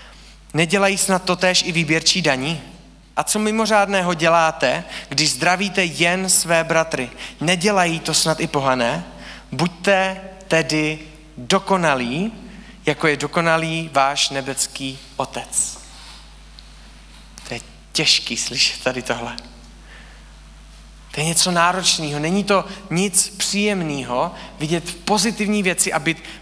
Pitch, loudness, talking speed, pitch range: 165 Hz, -18 LUFS, 110 wpm, 145-190 Hz